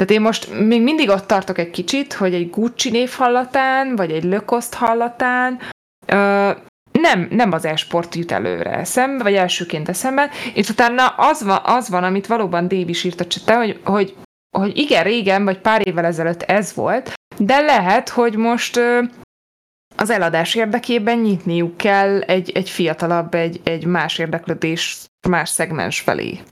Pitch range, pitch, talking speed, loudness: 175-235 Hz, 200 Hz, 160 wpm, -17 LUFS